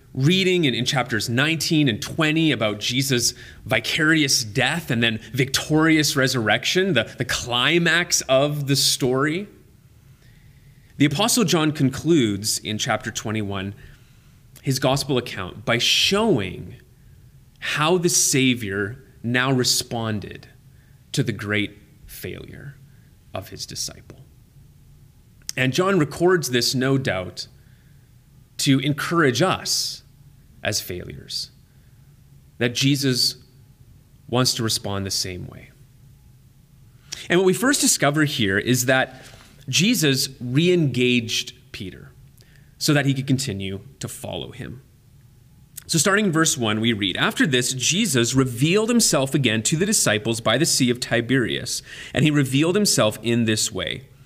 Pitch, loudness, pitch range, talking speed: 130 Hz, -20 LUFS, 120-145 Hz, 125 wpm